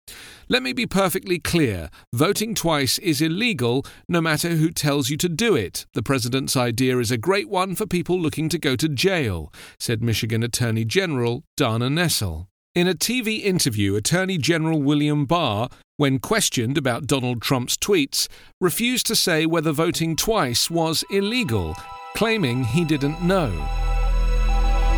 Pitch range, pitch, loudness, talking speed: 125-180 Hz, 160 Hz, -21 LUFS, 150 wpm